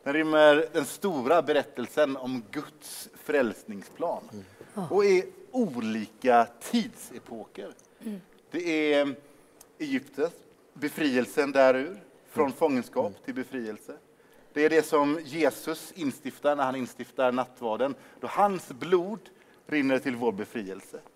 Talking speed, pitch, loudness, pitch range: 110 wpm, 150 Hz, -27 LUFS, 130-190 Hz